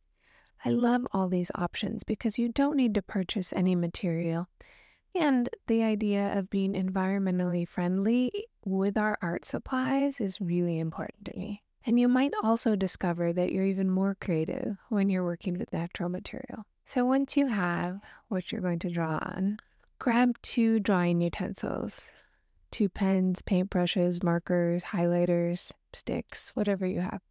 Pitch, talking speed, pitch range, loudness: 195 Hz, 150 wpm, 180-220 Hz, -29 LUFS